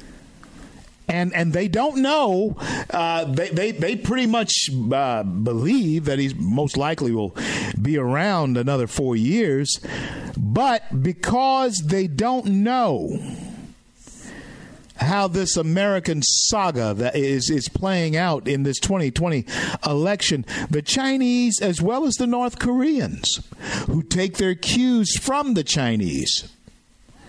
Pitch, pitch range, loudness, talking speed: 170 Hz, 140-220 Hz, -21 LUFS, 125 wpm